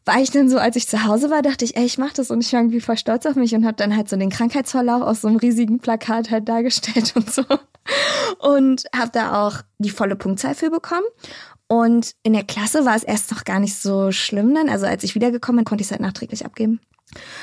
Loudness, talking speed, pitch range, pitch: -19 LUFS, 250 wpm, 215-255 Hz, 230 Hz